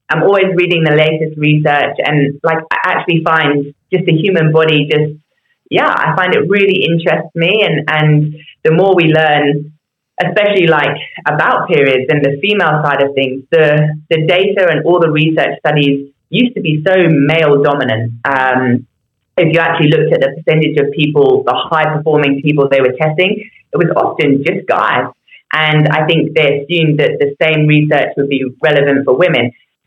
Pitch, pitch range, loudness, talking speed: 155 Hz, 145-165 Hz, -11 LUFS, 180 wpm